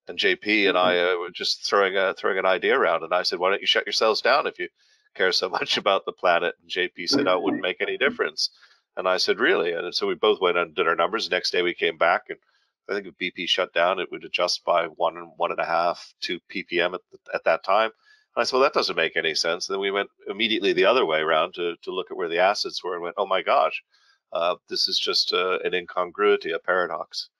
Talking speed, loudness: 265 wpm, -23 LUFS